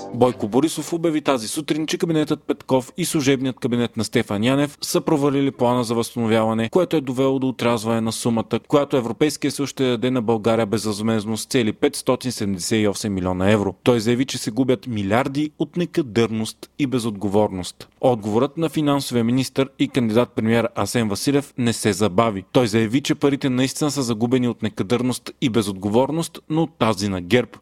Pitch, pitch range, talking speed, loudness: 125 Hz, 115-140 Hz, 165 wpm, -21 LUFS